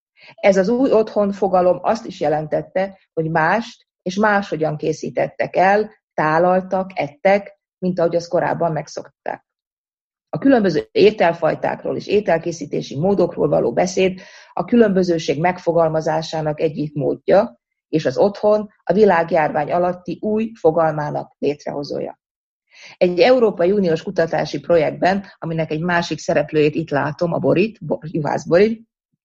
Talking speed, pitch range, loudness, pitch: 120 wpm, 160-205 Hz, -18 LUFS, 180 Hz